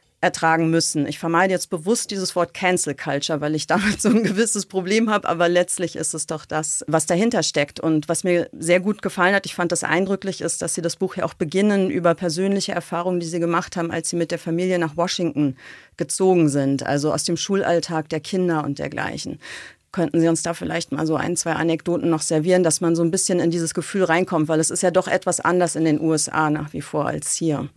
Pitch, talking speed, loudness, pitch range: 170 Hz, 230 wpm, -21 LUFS, 160-185 Hz